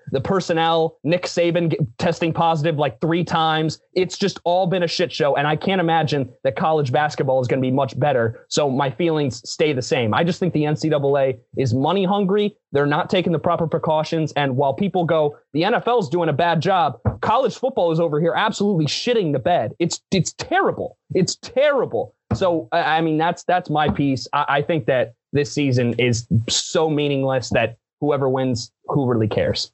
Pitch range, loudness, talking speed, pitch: 140-175 Hz, -20 LUFS, 190 wpm, 160 Hz